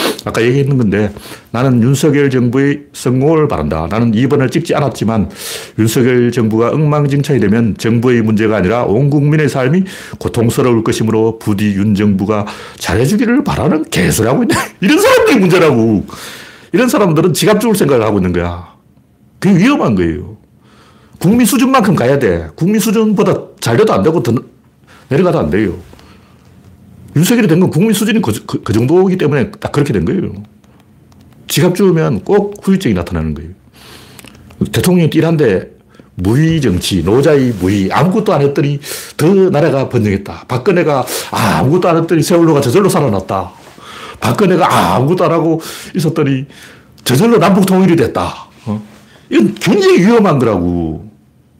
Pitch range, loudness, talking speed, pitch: 110-180 Hz, -12 LUFS, 345 characters per minute, 140 Hz